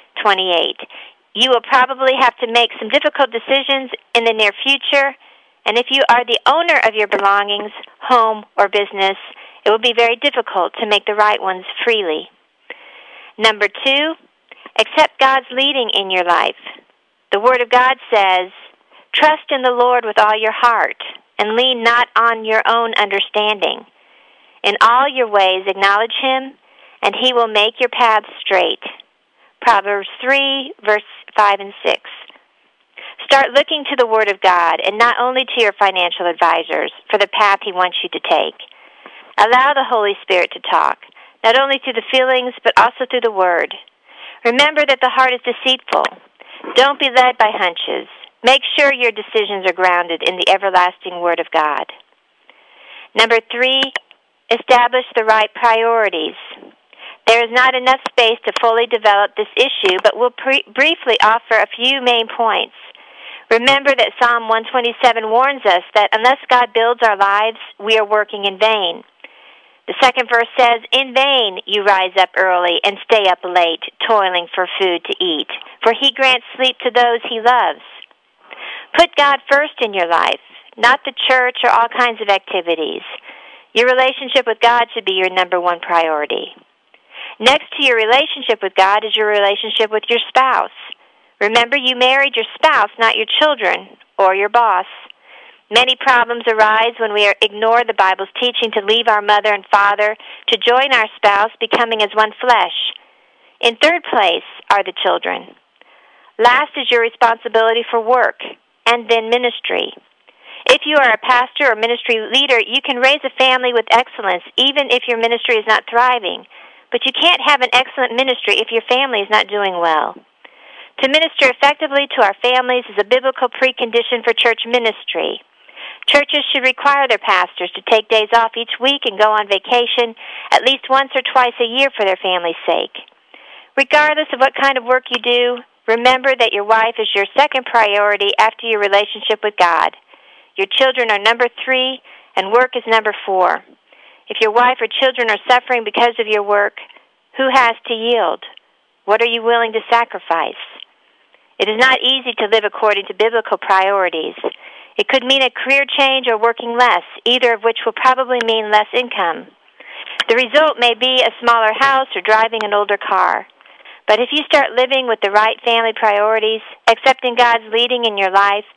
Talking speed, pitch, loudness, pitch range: 170 wpm, 235 Hz, -14 LUFS, 210-260 Hz